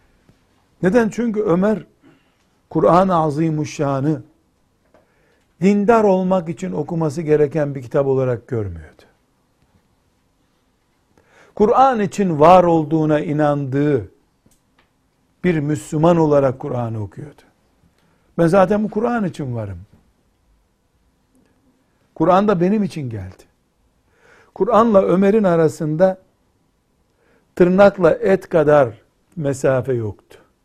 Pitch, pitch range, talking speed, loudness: 155 Hz, 130-185 Hz, 85 wpm, -17 LUFS